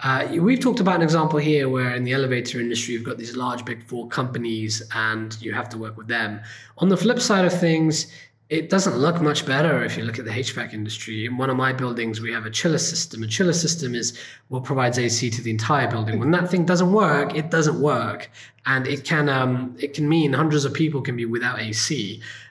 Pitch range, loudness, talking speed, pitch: 115-160 Hz, -22 LUFS, 230 wpm, 130 Hz